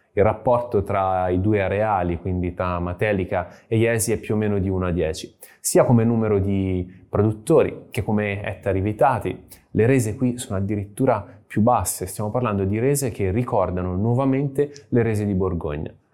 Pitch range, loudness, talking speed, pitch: 95-115 Hz, -22 LUFS, 170 wpm, 105 Hz